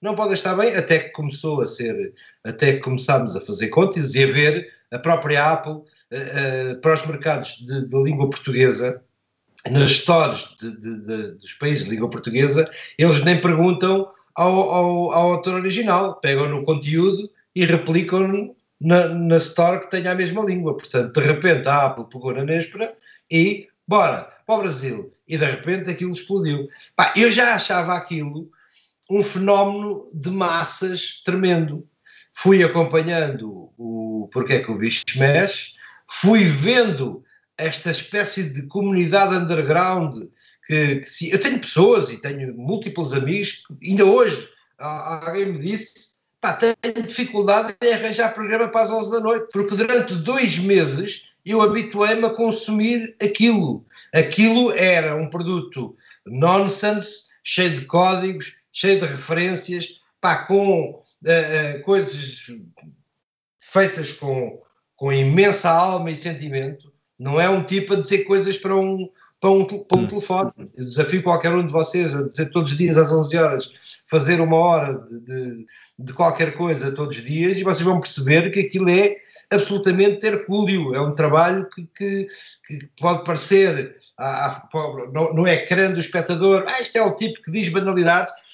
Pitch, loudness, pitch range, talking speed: 175 Hz, -19 LUFS, 150-195 Hz, 160 wpm